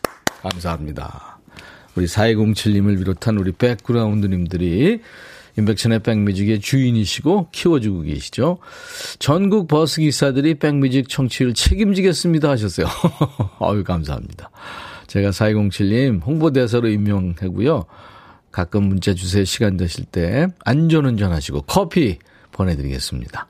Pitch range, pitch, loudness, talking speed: 95-145 Hz, 110 Hz, -18 LUFS, 295 characters per minute